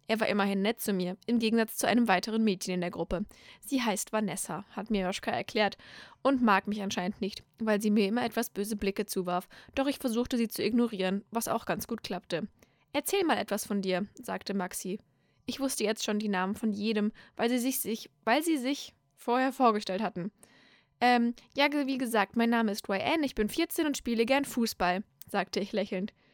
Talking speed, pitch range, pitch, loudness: 200 wpm, 195-240 Hz, 215 Hz, -30 LUFS